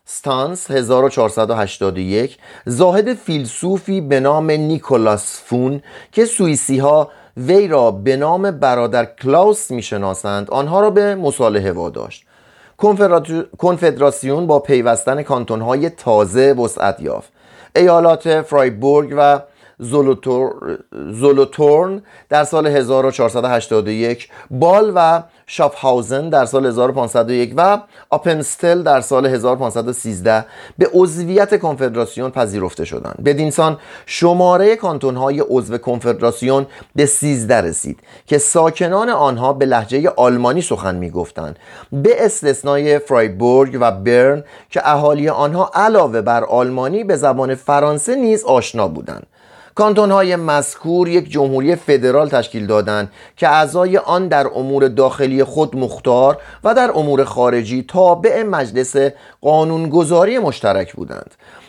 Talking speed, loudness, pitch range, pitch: 115 wpm, -15 LUFS, 125-165 Hz, 140 Hz